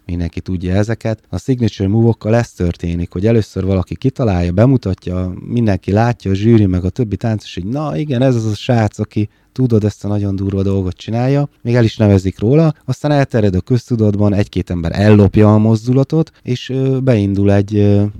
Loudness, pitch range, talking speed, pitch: -15 LUFS, 95-125 Hz, 175 wpm, 105 Hz